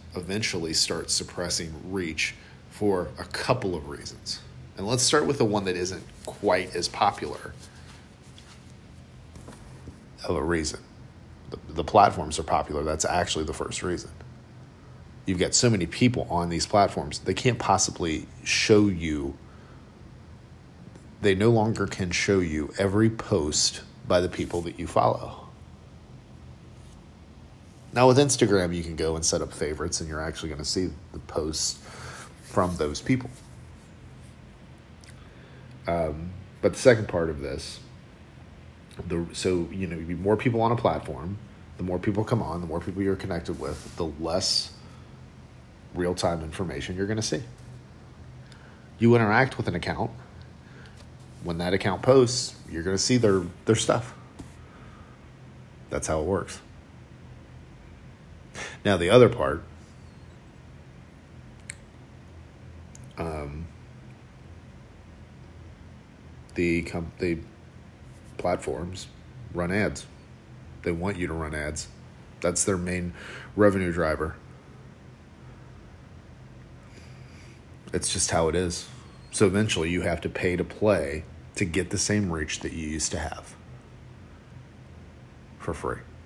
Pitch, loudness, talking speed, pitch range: 90 Hz, -26 LUFS, 130 wpm, 80-105 Hz